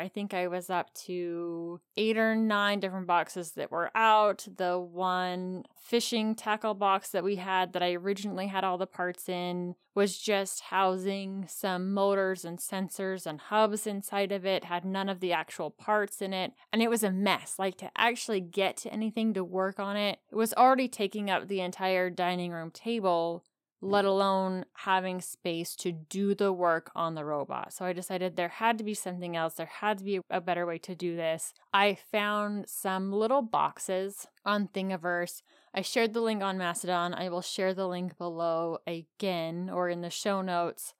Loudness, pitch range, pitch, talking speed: -31 LUFS, 180-205 Hz, 190 Hz, 190 wpm